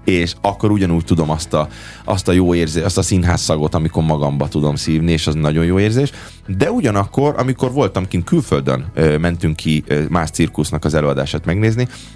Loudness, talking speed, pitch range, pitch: -17 LUFS, 185 wpm, 80-100 Hz, 85 Hz